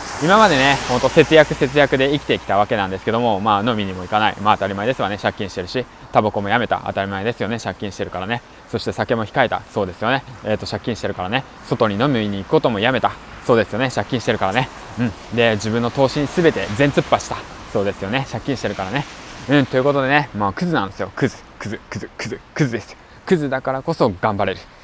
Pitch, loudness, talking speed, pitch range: 120 Hz, -19 LUFS, 480 characters per minute, 105-140 Hz